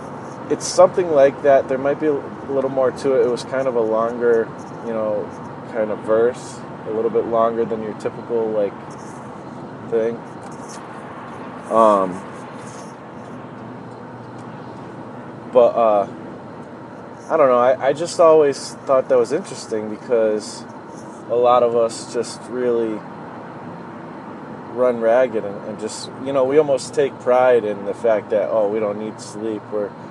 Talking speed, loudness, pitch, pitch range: 145 wpm, -19 LUFS, 120 Hz, 110-130 Hz